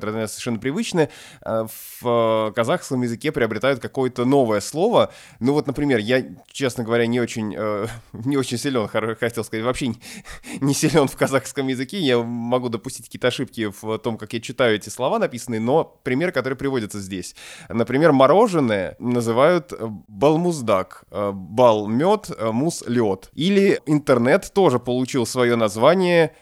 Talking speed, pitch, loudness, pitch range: 135 wpm, 120 Hz, -21 LUFS, 110-135 Hz